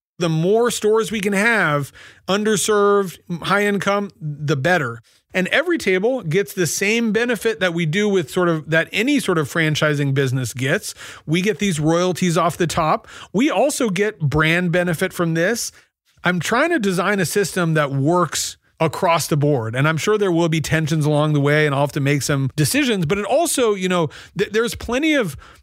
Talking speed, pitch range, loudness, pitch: 190 wpm, 155-205 Hz, -19 LUFS, 180 Hz